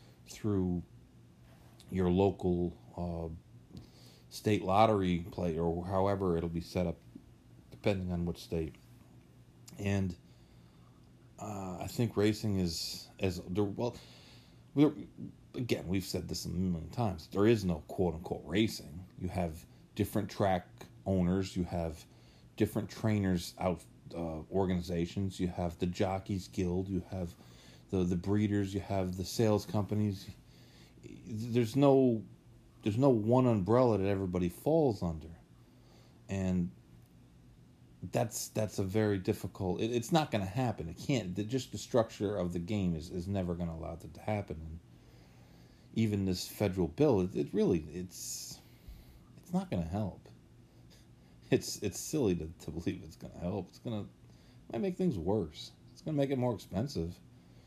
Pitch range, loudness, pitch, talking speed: 85-105 Hz, -34 LUFS, 95 Hz, 150 wpm